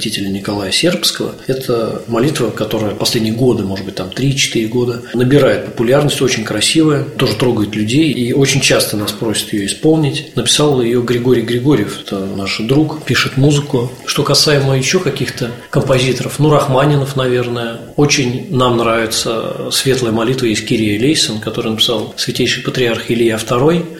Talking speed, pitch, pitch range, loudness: 145 wpm, 125 Hz, 115-135 Hz, -14 LUFS